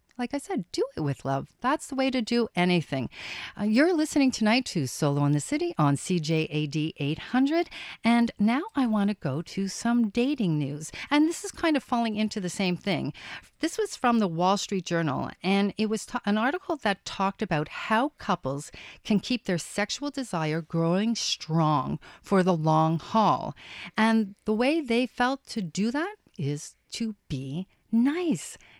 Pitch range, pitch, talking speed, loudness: 165-255 Hz, 210 Hz, 180 wpm, -27 LUFS